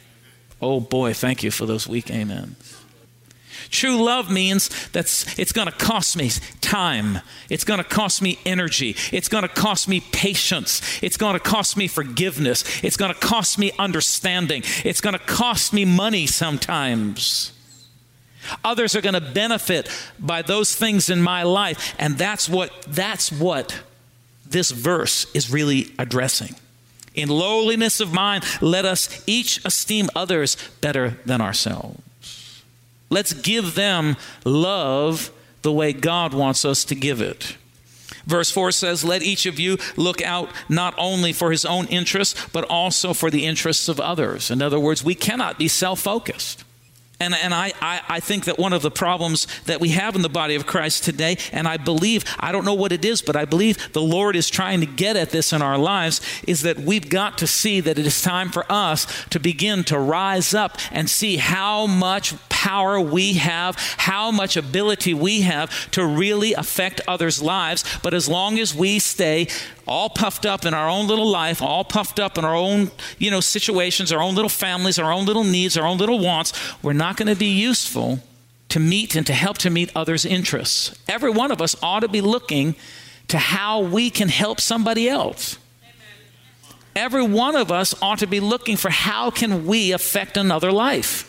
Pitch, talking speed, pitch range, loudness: 175 Hz, 185 wpm, 150-200 Hz, -20 LUFS